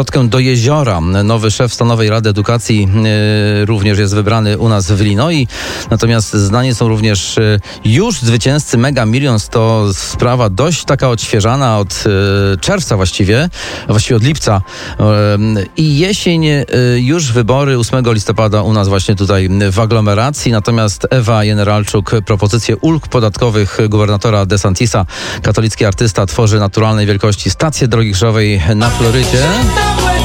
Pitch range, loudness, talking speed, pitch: 105-125 Hz, -11 LUFS, 135 wpm, 110 Hz